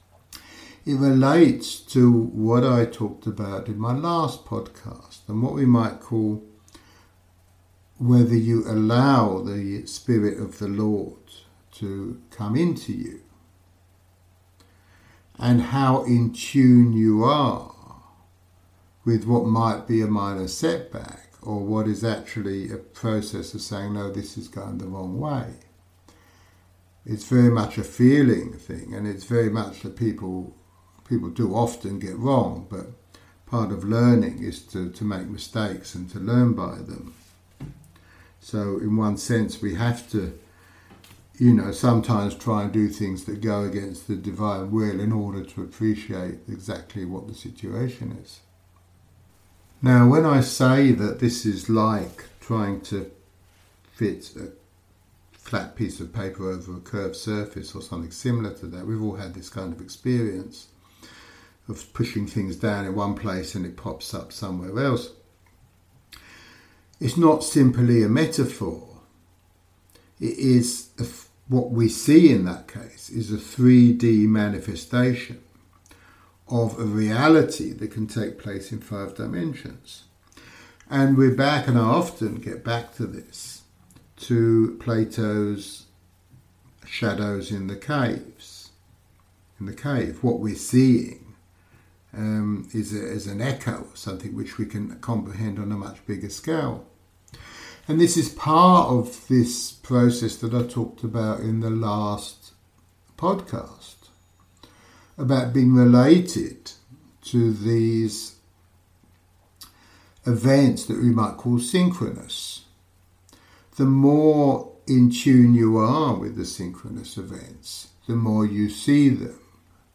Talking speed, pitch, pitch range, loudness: 135 wpm, 105 Hz, 95-120 Hz, -22 LUFS